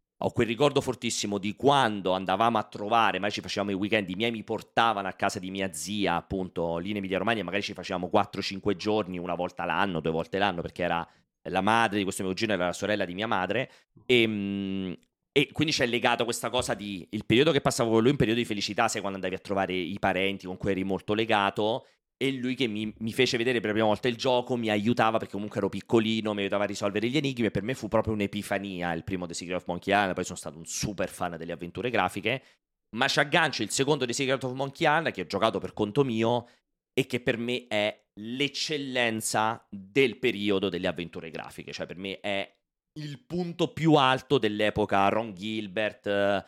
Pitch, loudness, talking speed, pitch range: 105 Hz, -28 LUFS, 215 wpm, 95-120 Hz